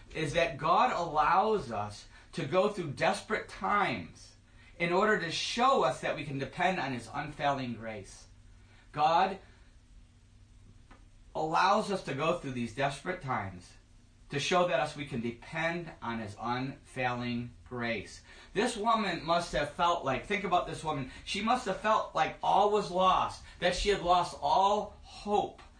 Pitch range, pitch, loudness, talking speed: 115-180 Hz, 145 Hz, -31 LUFS, 155 wpm